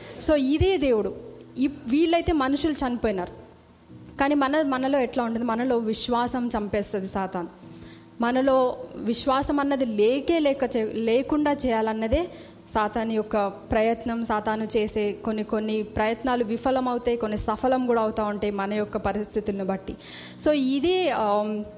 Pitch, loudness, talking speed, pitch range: 230 Hz, -25 LUFS, 120 wpm, 215-265 Hz